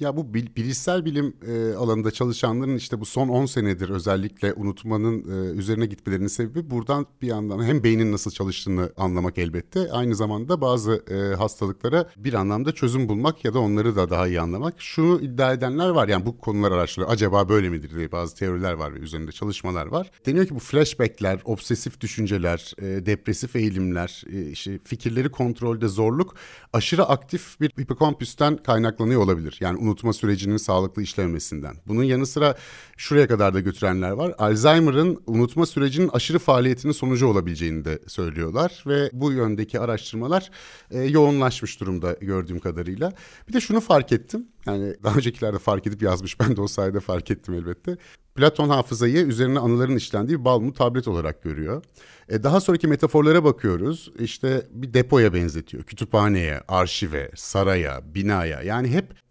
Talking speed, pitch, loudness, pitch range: 150 wpm, 115 Hz, -23 LUFS, 95-135 Hz